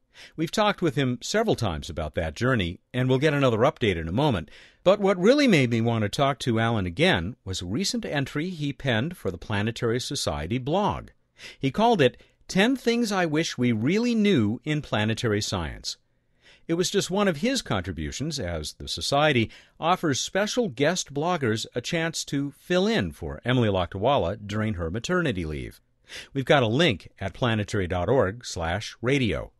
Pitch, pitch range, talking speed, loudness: 130 Hz, 105-175 Hz, 170 wpm, -25 LUFS